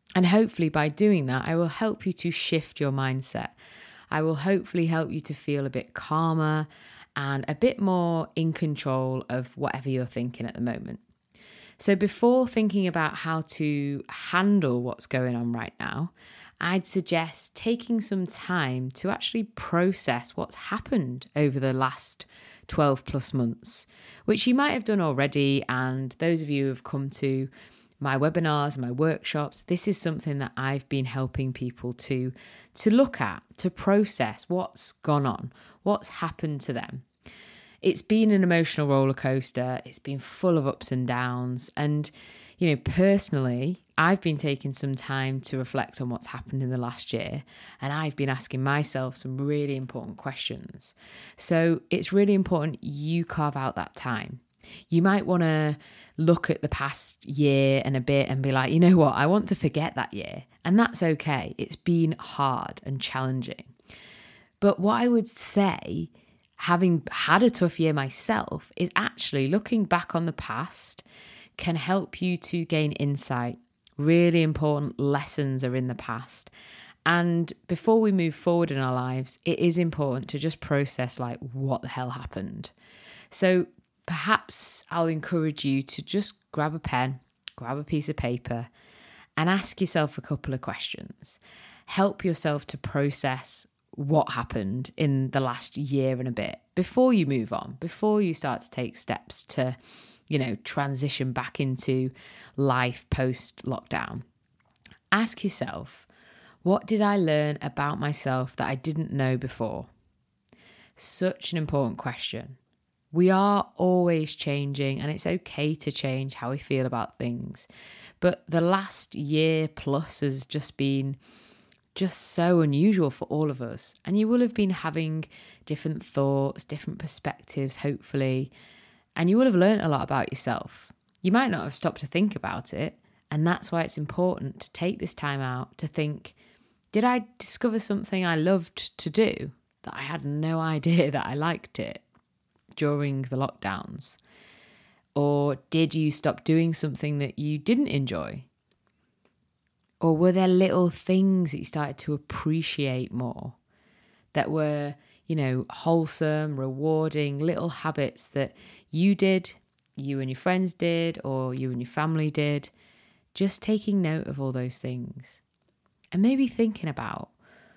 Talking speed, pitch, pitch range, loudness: 160 wpm, 150 Hz, 135-175 Hz, -27 LUFS